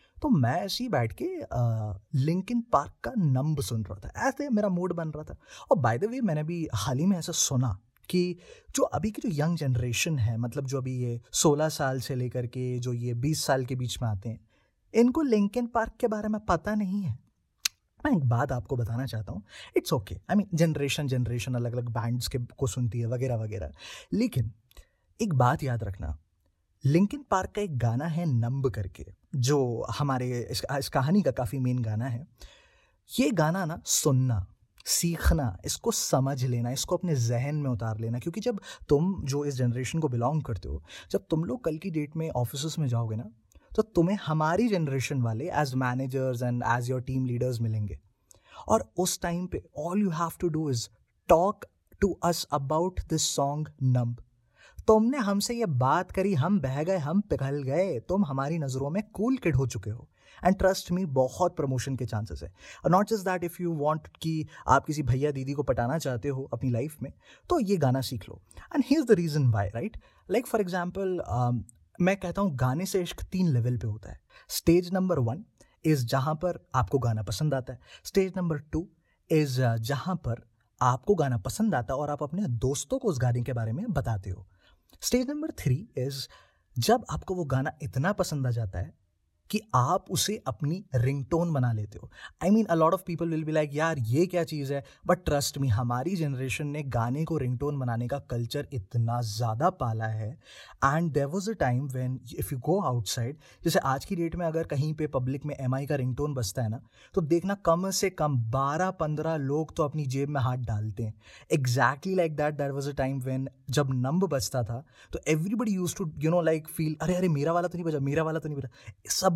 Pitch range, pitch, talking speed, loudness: 125-175 Hz, 140 Hz, 205 wpm, -29 LUFS